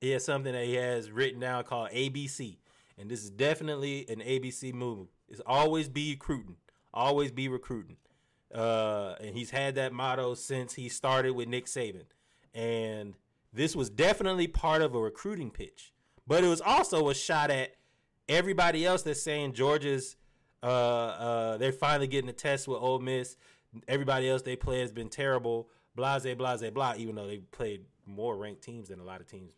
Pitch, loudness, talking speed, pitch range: 130 Hz, -31 LUFS, 185 wpm, 115-140 Hz